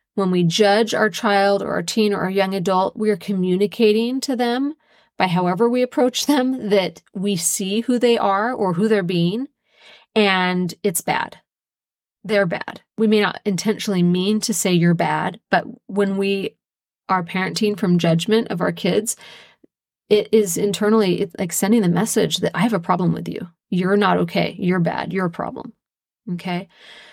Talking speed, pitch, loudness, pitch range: 175 wpm, 200 Hz, -19 LUFS, 185-220 Hz